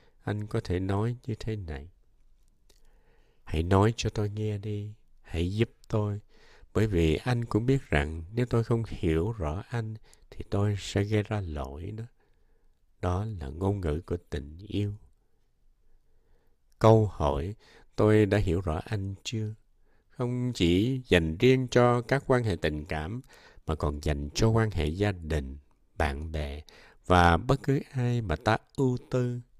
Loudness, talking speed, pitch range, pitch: -29 LUFS, 160 wpm, 80-115 Hz, 100 Hz